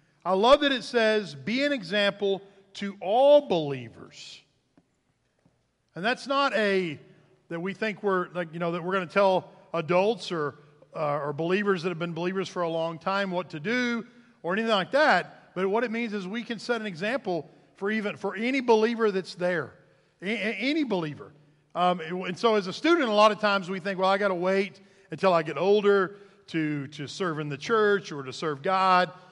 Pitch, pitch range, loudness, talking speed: 190 Hz, 170-215 Hz, -26 LUFS, 200 wpm